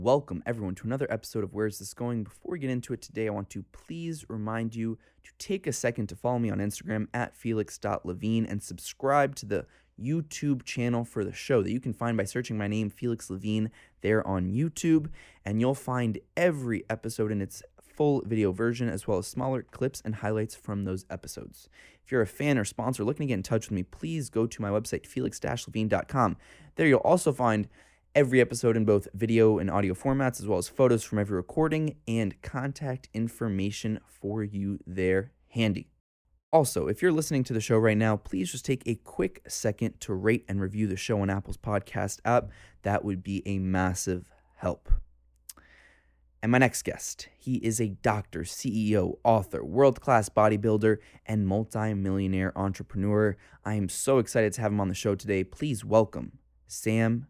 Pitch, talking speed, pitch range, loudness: 110 Hz, 190 wpm, 100-120 Hz, -29 LUFS